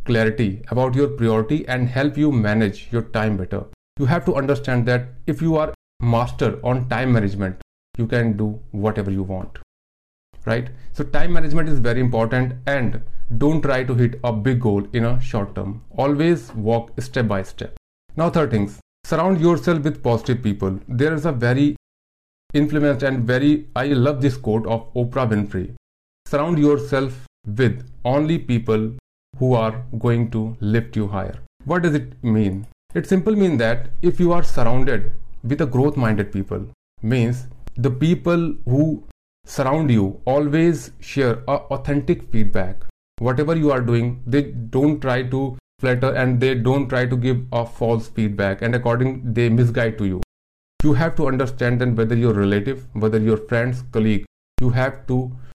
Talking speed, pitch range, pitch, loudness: 165 wpm, 110-140 Hz, 125 Hz, -21 LUFS